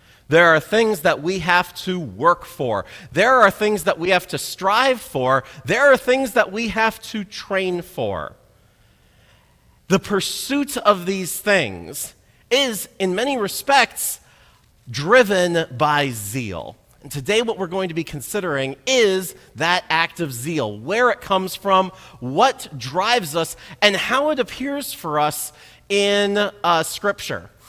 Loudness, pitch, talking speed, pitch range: -19 LUFS, 185 Hz, 145 wpm, 155-210 Hz